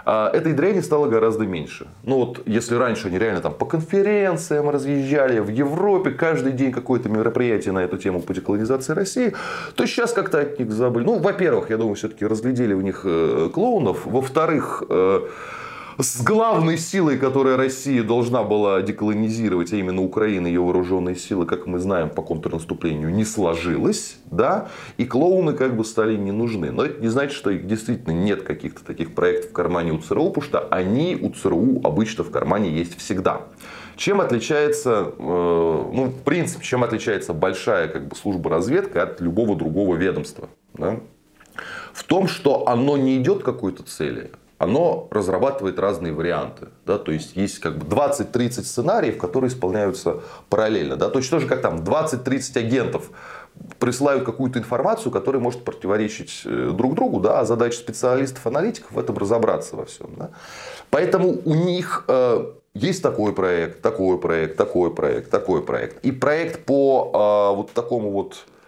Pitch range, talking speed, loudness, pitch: 100-145 Hz, 160 wpm, -21 LUFS, 120 Hz